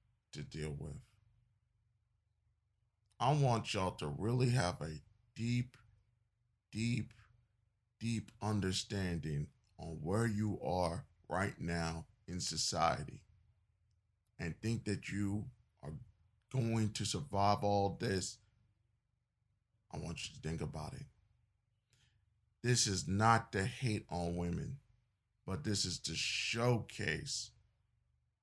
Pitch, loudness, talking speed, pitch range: 110 Hz, -38 LUFS, 110 wpm, 100-115 Hz